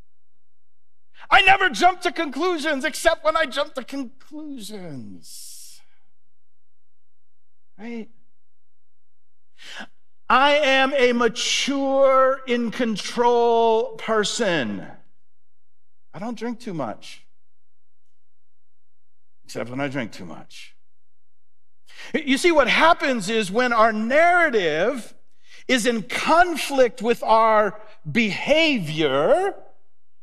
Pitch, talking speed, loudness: 220 Hz, 85 wpm, -20 LUFS